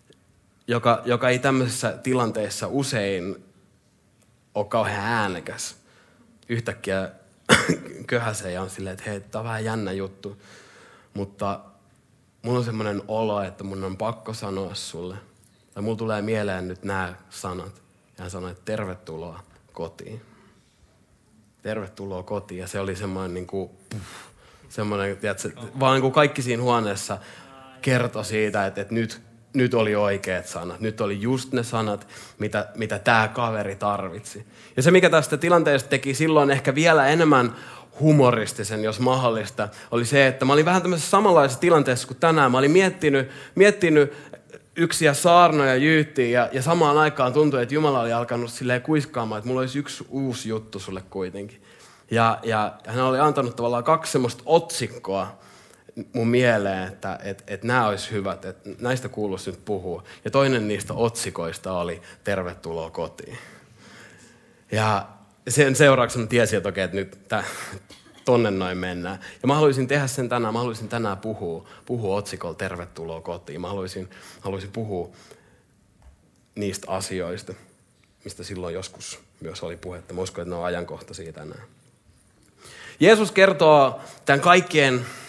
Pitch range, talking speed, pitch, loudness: 100-130 Hz, 145 wpm, 110 Hz, -22 LUFS